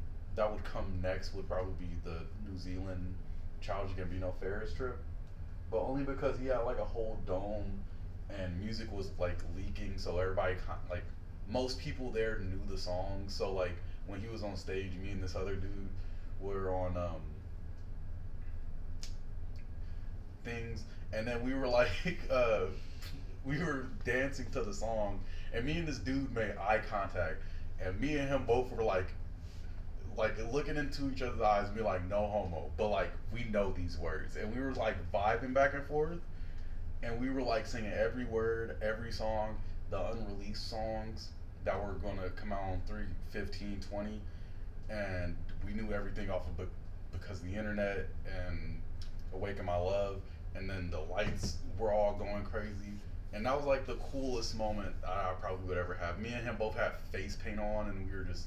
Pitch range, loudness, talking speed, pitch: 90-105 Hz, -39 LUFS, 180 wpm, 95 Hz